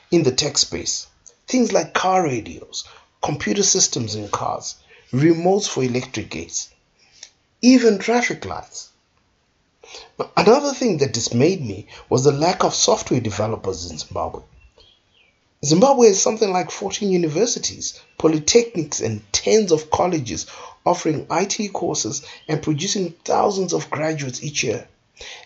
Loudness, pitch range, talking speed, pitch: -19 LUFS, 130-200 Hz, 125 wpm, 165 Hz